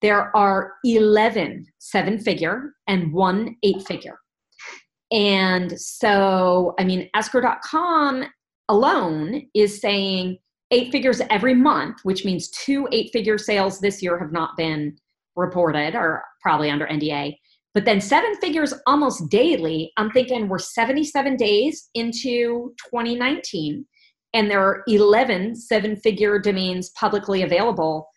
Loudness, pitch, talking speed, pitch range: -20 LUFS, 210 Hz, 125 wpm, 185-245 Hz